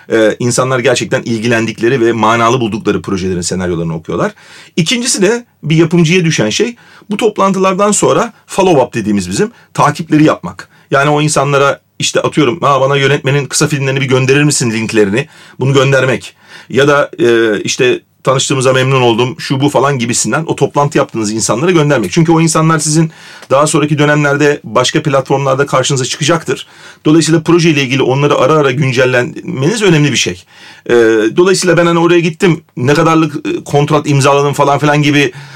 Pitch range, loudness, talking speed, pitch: 130-165 Hz, -11 LUFS, 155 wpm, 145 Hz